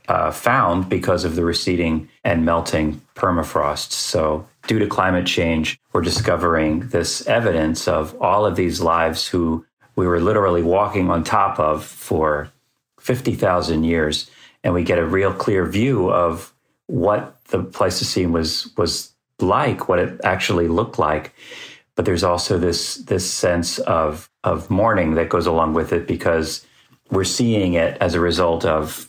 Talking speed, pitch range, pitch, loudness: 160 wpm, 80-90 Hz, 85 Hz, -19 LUFS